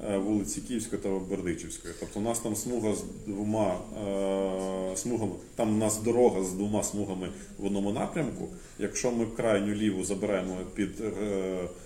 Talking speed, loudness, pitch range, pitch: 140 wpm, -31 LUFS, 95-110 Hz, 100 Hz